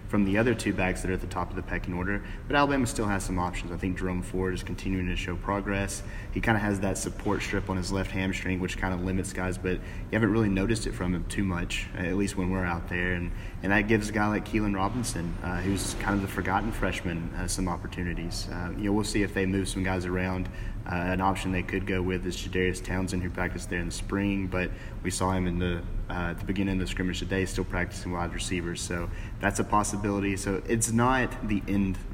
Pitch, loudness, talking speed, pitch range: 95 Hz, -29 LUFS, 250 wpm, 90-100 Hz